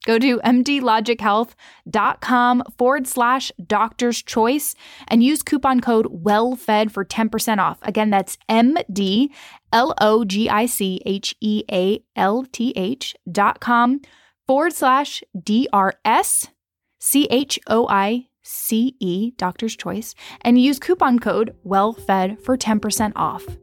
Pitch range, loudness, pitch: 210-255 Hz, -19 LUFS, 225 Hz